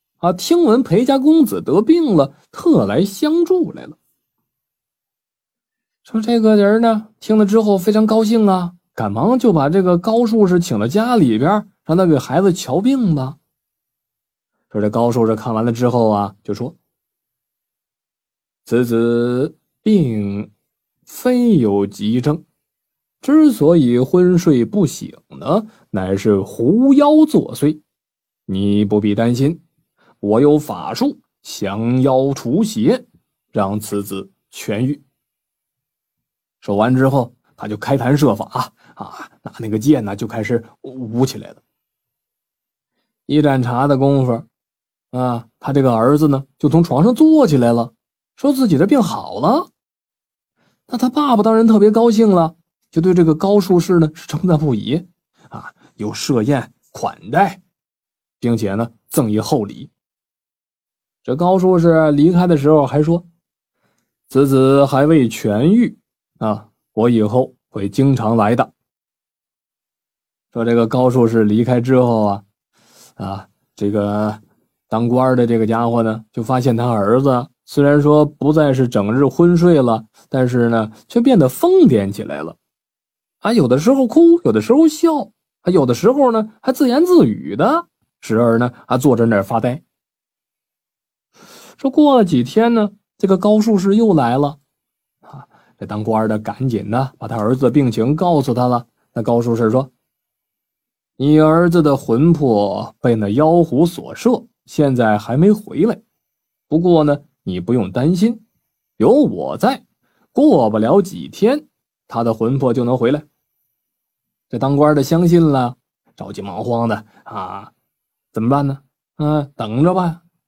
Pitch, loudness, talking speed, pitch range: 140 Hz, -15 LUFS, 200 characters per minute, 115-185 Hz